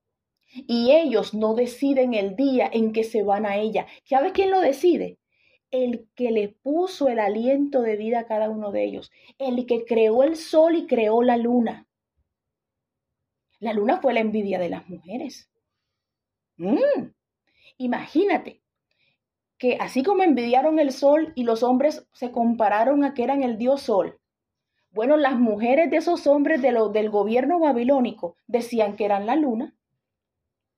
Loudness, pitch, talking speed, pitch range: -22 LUFS, 245 Hz, 160 wpm, 215-280 Hz